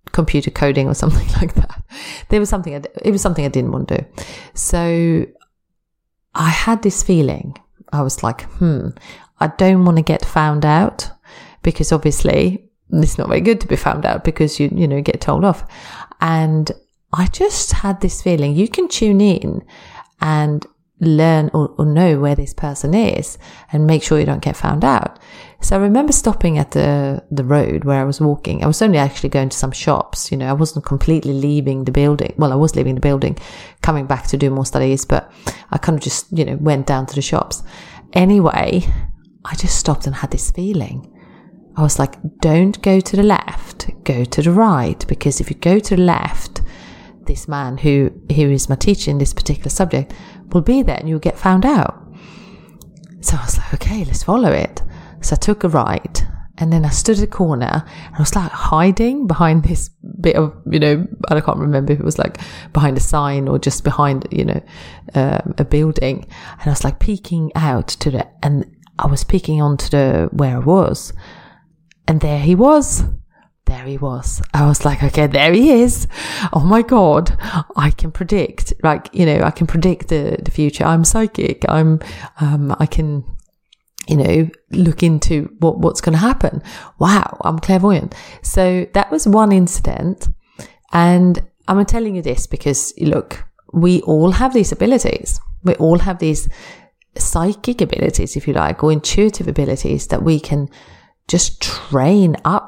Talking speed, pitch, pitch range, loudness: 190 wpm, 160 Hz, 145-185 Hz, -16 LUFS